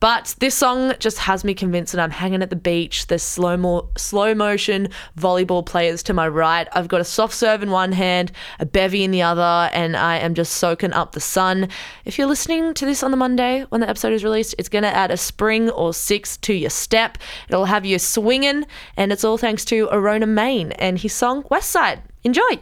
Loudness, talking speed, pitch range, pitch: -19 LUFS, 225 wpm, 175-225 Hz, 195 Hz